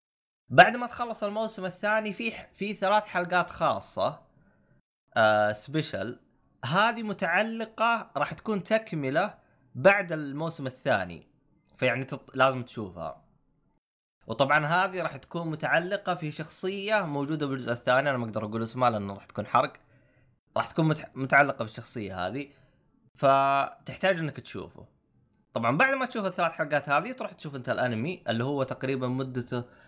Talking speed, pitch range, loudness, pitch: 135 wpm, 130-190 Hz, -28 LUFS, 145 Hz